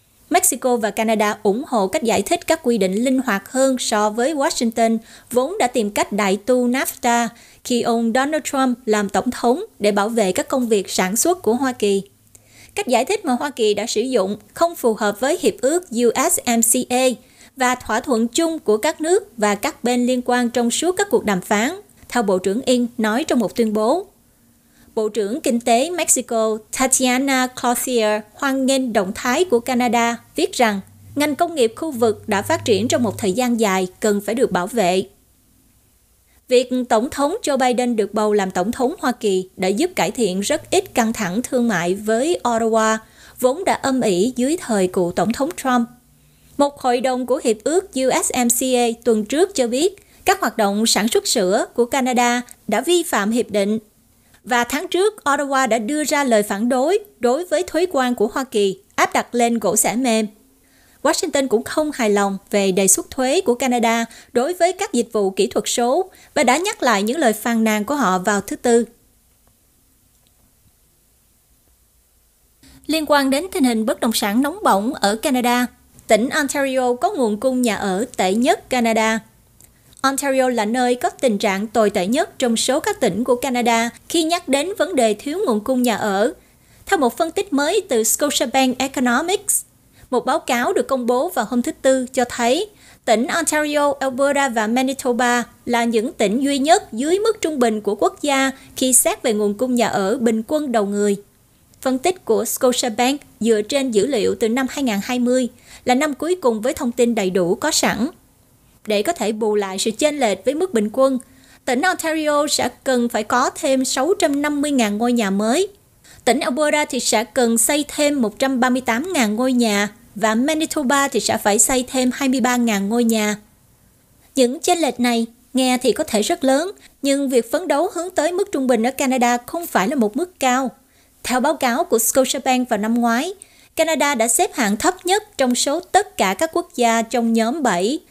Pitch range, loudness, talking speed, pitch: 220-285 Hz, -19 LUFS, 190 wpm, 245 Hz